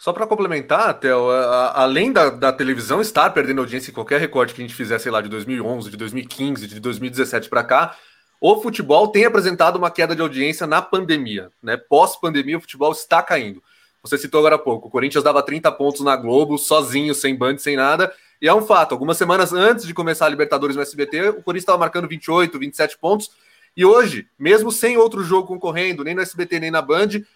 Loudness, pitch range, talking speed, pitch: -18 LUFS, 135-185 Hz, 205 wpm, 155 Hz